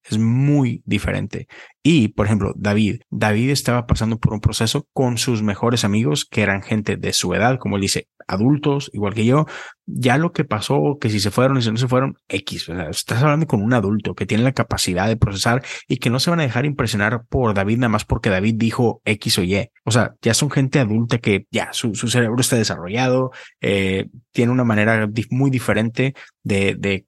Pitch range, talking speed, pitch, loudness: 105-130 Hz, 215 wpm, 115 Hz, -19 LUFS